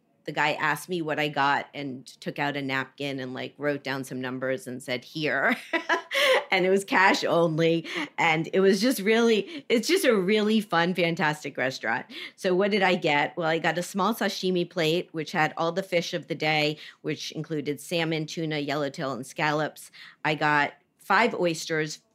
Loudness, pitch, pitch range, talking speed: -26 LUFS, 160 Hz, 145-185 Hz, 185 wpm